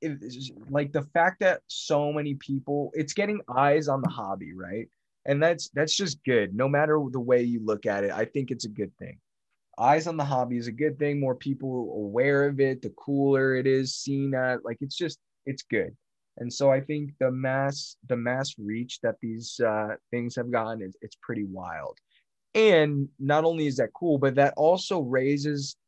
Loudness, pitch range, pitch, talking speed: -27 LUFS, 125-150 Hz, 135 Hz, 205 wpm